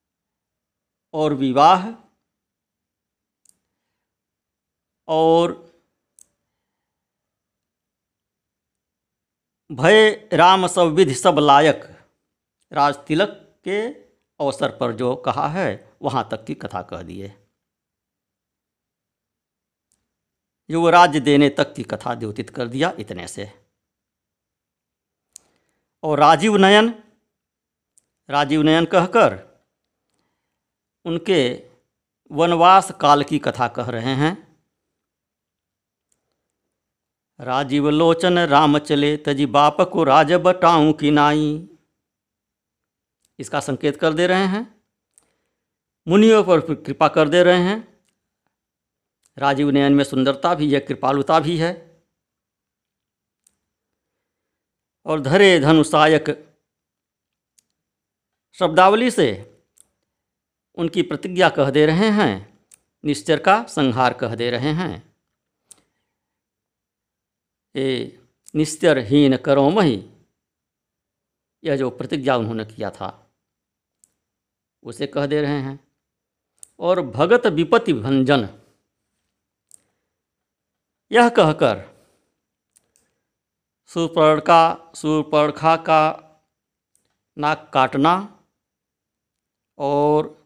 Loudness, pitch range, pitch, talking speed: -17 LUFS, 135-170 Hz, 150 Hz, 85 wpm